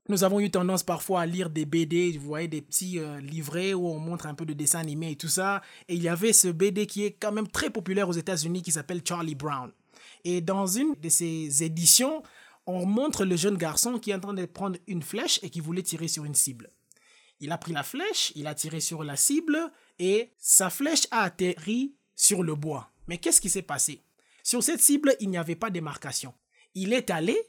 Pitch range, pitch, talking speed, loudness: 160-205 Hz, 180 Hz, 230 wpm, -26 LUFS